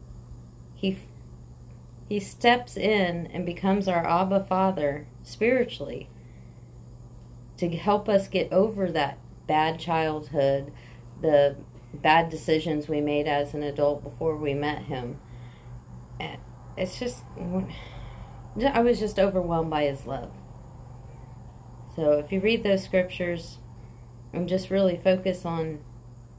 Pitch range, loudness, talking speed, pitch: 120-185 Hz, -26 LUFS, 115 wpm, 150 Hz